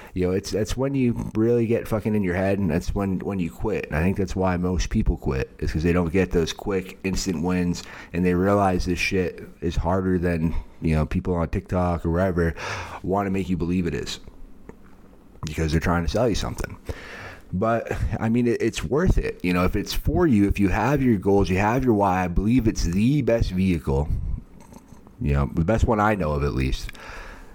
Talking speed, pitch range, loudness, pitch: 220 wpm, 85-105 Hz, -24 LUFS, 95 Hz